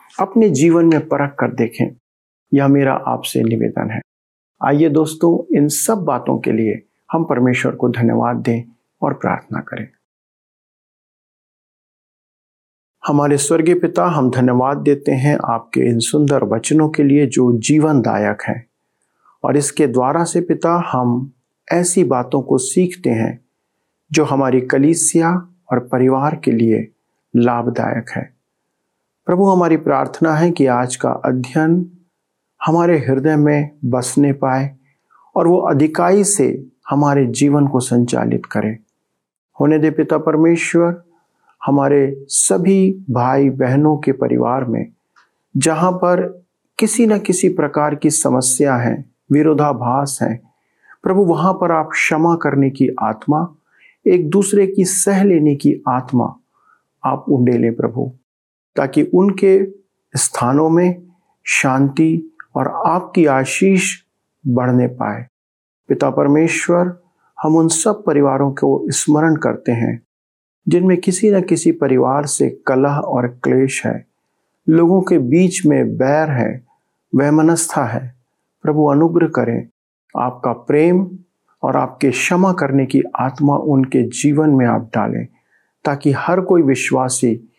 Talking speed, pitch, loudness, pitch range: 125 wpm, 145 Hz, -15 LUFS, 125-170 Hz